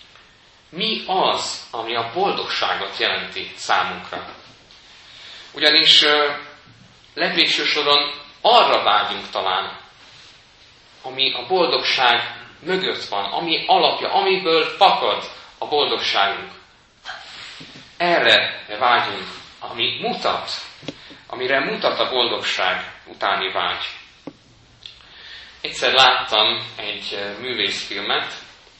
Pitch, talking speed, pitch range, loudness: 150 Hz, 75 wpm, 135-155 Hz, -18 LUFS